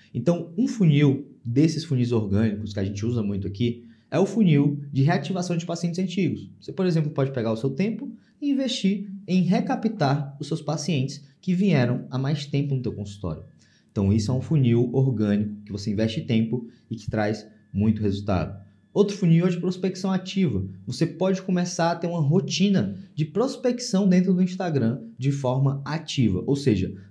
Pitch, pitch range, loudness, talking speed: 145 Hz, 115-185 Hz, -24 LUFS, 180 wpm